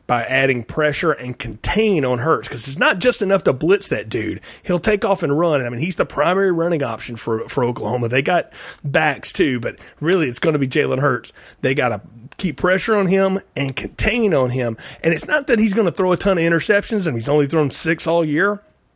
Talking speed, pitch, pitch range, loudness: 230 wpm, 165 Hz, 130-195 Hz, -18 LUFS